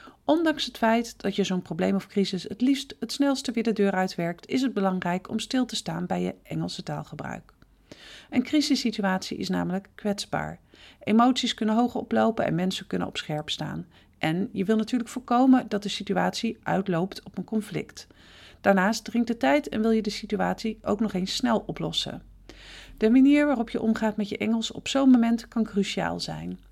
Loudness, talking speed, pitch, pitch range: -26 LUFS, 185 wpm, 215 Hz, 190-240 Hz